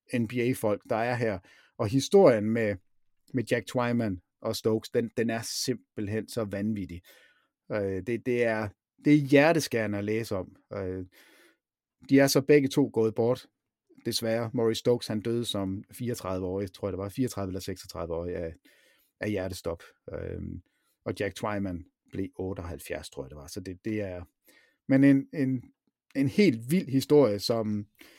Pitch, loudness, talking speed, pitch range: 110 Hz, -28 LUFS, 160 wpm, 100-125 Hz